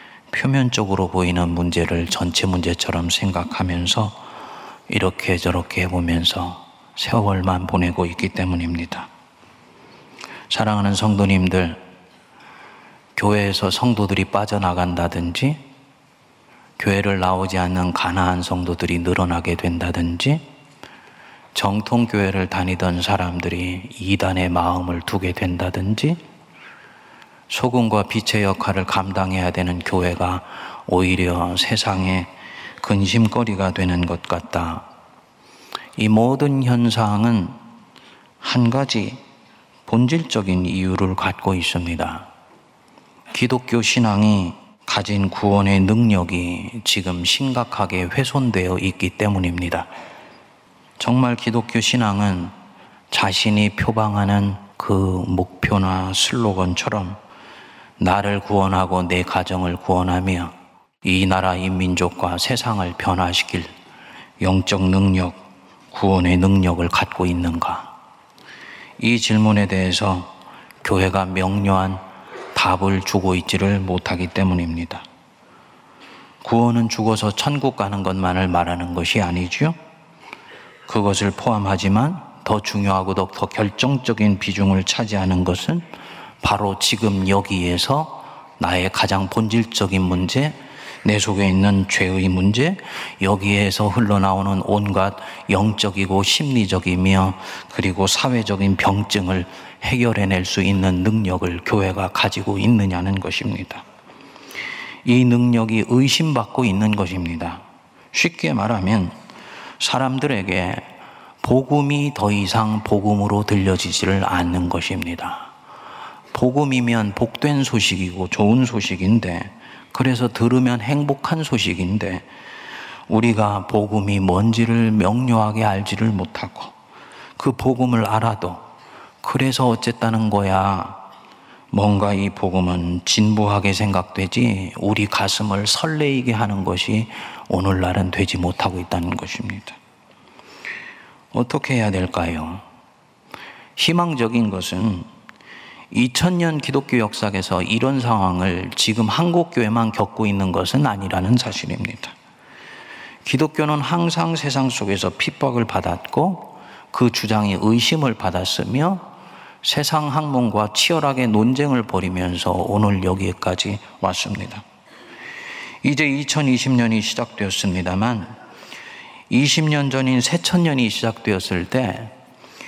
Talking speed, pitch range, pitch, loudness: 245 characters per minute, 90-115 Hz, 100 Hz, -19 LUFS